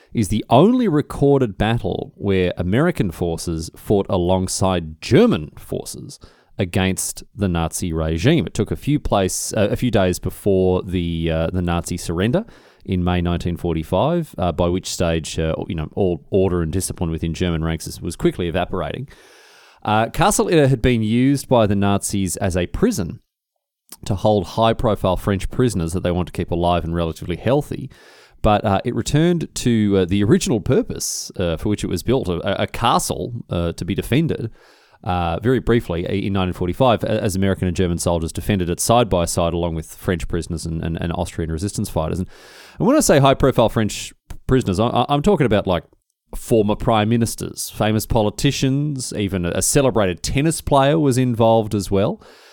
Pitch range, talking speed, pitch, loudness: 90-115 Hz, 170 wpm, 100 Hz, -19 LUFS